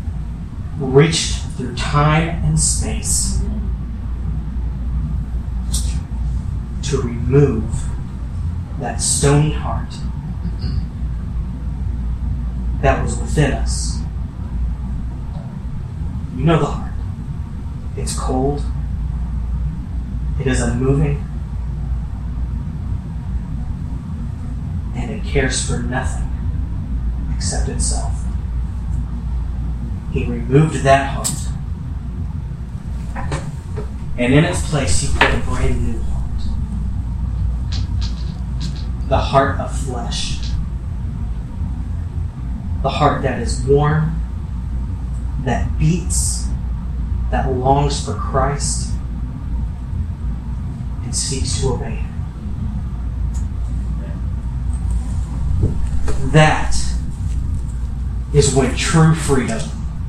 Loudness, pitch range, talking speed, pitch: -20 LUFS, 65-90 Hz, 70 wpm, 80 Hz